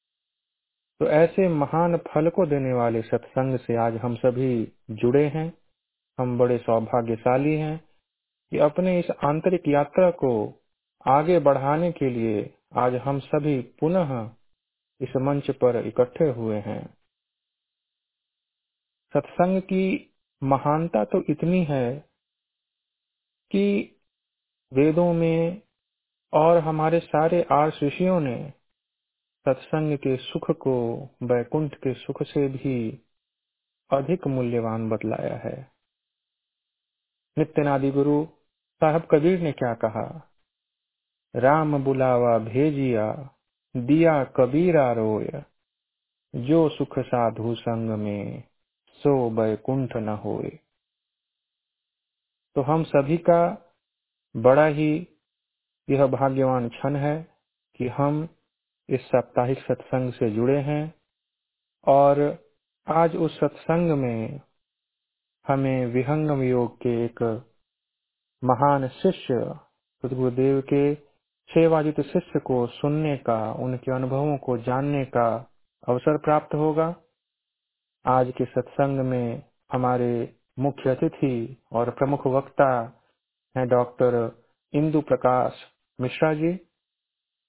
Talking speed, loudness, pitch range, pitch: 95 wpm, -24 LUFS, 125-155 Hz, 135 Hz